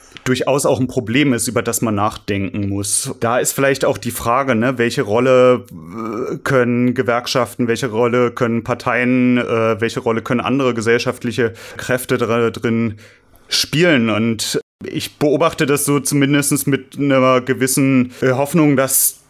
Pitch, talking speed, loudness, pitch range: 125 Hz, 140 wpm, -16 LUFS, 115-135 Hz